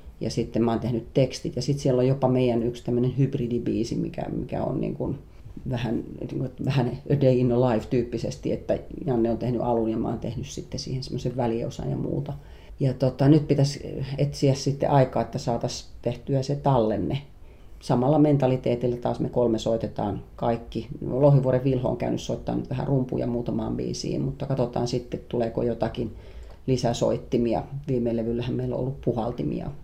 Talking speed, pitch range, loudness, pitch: 170 wpm, 115-135 Hz, -26 LUFS, 125 Hz